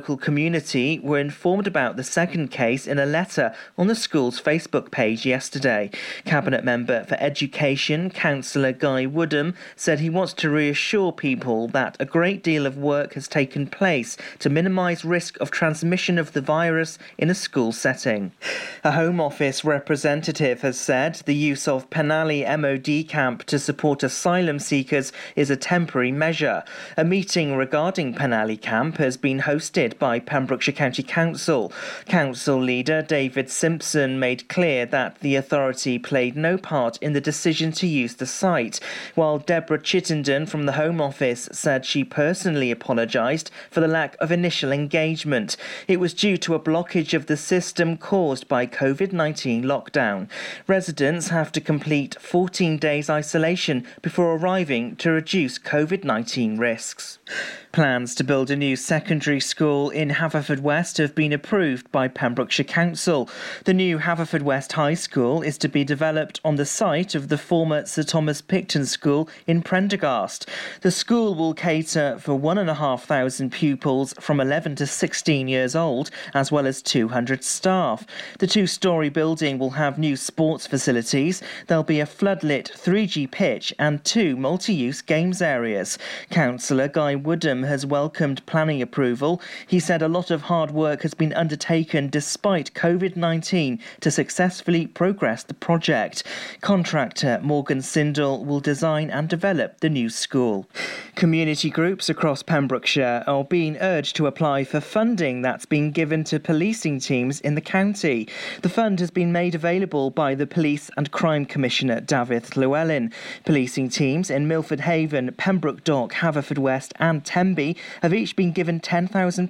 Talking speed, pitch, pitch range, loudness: 155 wpm, 155 Hz, 140-170 Hz, -22 LUFS